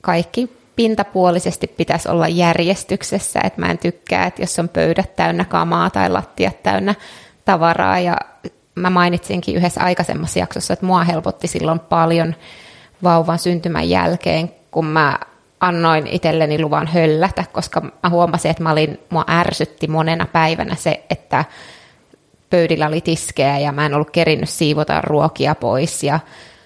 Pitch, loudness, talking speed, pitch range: 165 Hz, -17 LUFS, 140 wpm, 160-180 Hz